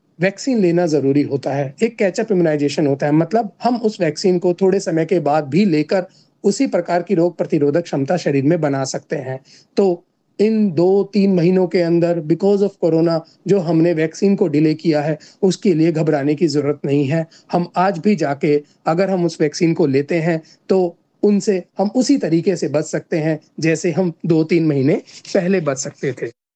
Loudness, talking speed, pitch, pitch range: -17 LUFS, 190 wpm, 170 Hz, 155-190 Hz